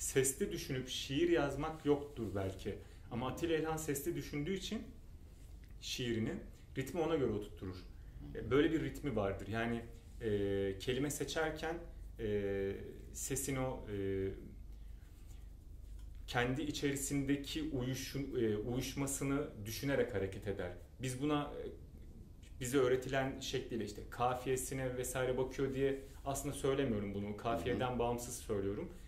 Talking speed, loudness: 110 wpm, -39 LUFS